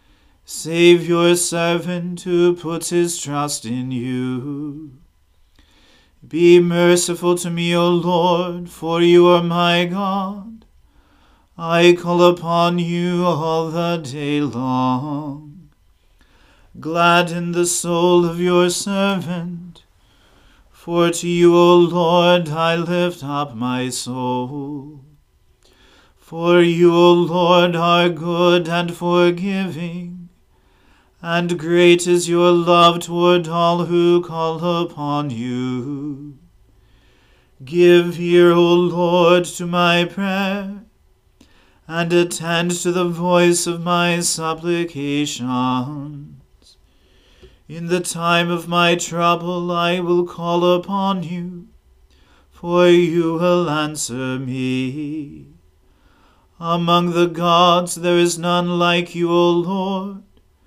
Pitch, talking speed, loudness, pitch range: 170 Hz, 105 wpm, -17 LUFS, 145-175 Hz